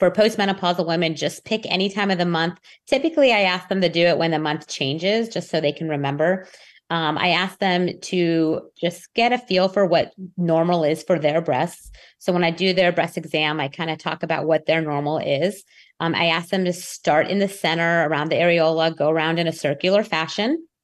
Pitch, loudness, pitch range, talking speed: 170 Hz, -21 LUFS, 160-185 Hz, 220 wpm